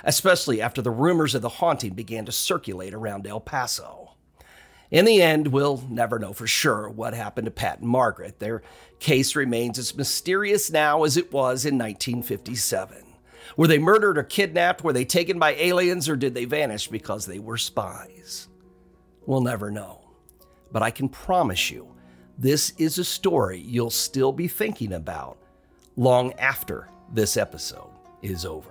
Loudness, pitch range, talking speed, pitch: -23 LUFS, 110-155 Hz, 165 wpm, 125 Hz